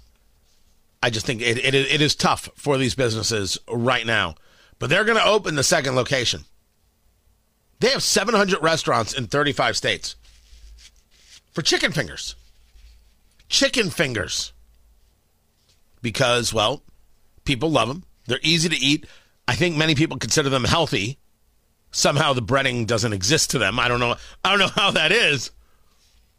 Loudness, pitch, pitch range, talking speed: -20 LUFS, 120 Hz, 90-145 Hz, 150 wpm